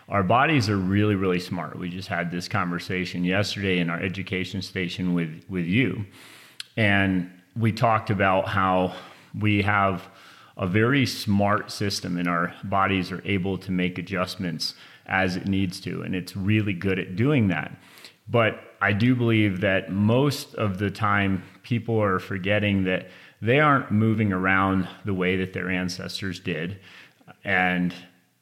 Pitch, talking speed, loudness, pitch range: 95 Hz, 155 wpm, -24 LUFS, 90-105 Hz